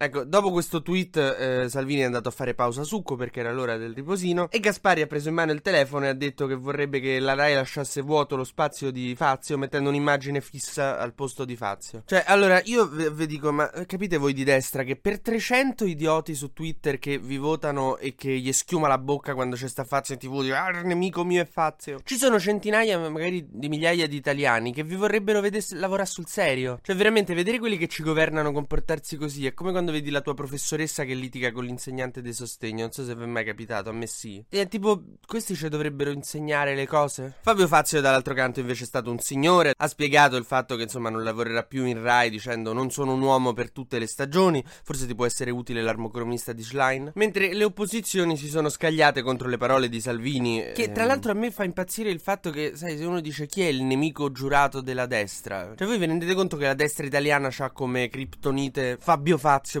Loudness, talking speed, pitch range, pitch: -25 LUFS, 225 wpm, 130-170 Hz, 145 Hz